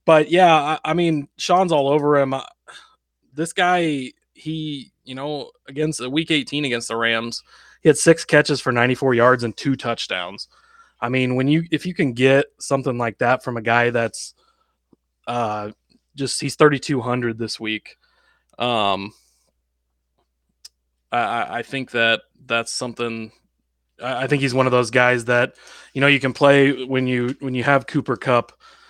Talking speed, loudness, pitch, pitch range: 165 wpm, -20 LUFS, 130 Hz, 120-145 Hz